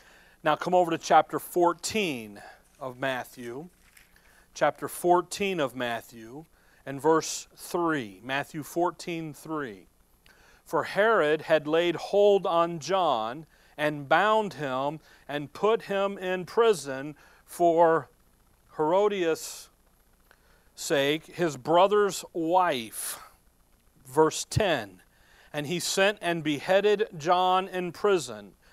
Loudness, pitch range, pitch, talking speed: -27 LUFS, 140-185 Hz, 160 Hz, 100 wpm